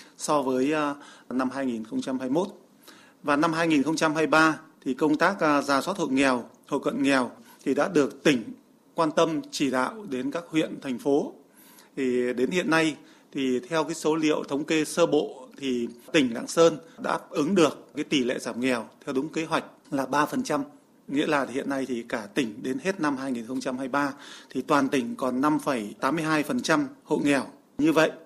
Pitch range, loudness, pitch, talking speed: 130-160 Hz, -26 LUFS, 145 Hz, 175 wpm